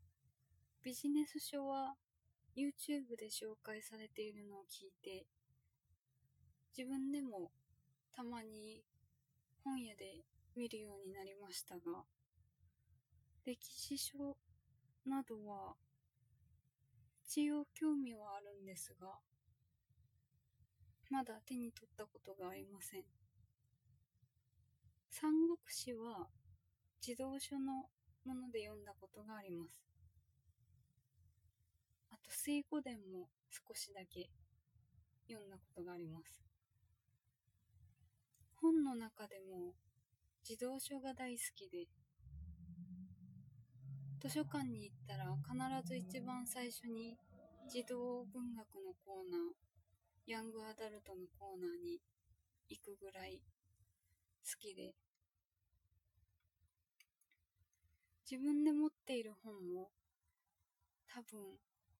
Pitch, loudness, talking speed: 190 Hz, -47 LUFS, 180 characters per minute